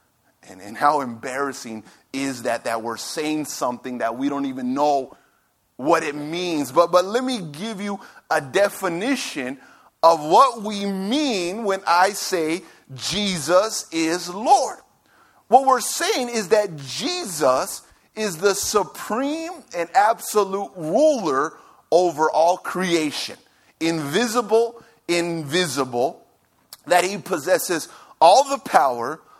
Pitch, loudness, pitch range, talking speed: 180 Hz, -21 LUFS, 155-220 Hz, 120 wpm